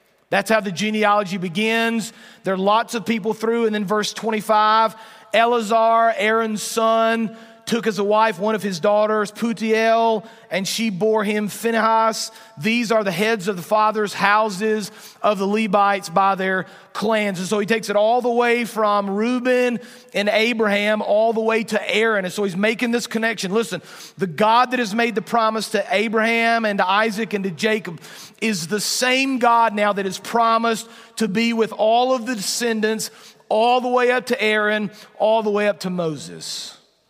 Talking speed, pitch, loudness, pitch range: 180 wpm, 220 Hz, -19 LUFS, 210-230 Hz